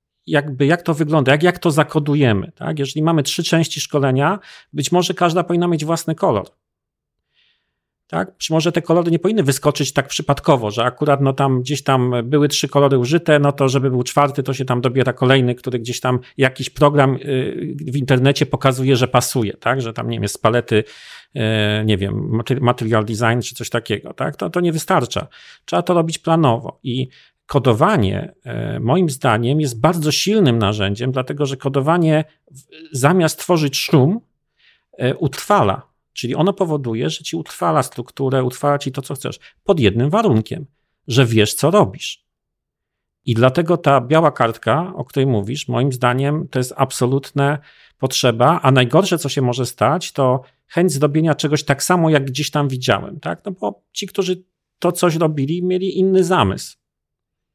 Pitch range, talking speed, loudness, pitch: 130-160 Hz, 165 wpm, -17 LUFS, 140 Hz